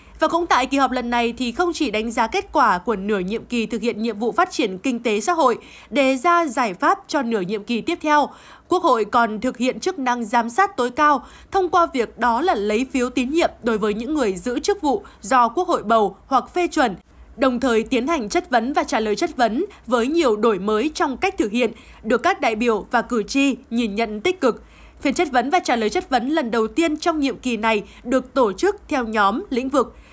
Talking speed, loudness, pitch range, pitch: 245 wpm, -20 LUFS, 230-325 Hz, 255 Hz